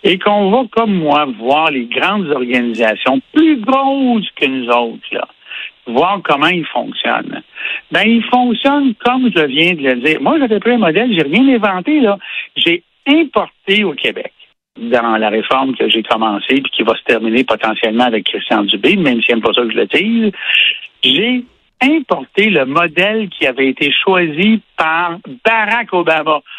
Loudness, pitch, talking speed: -13 LUFS, 195 Hz, 170 wpm